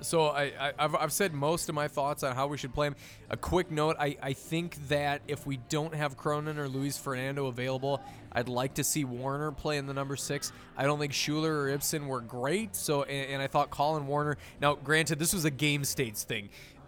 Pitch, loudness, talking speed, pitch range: 145 Hz, -31 LUFS, 230 wpm, 135-150 Hz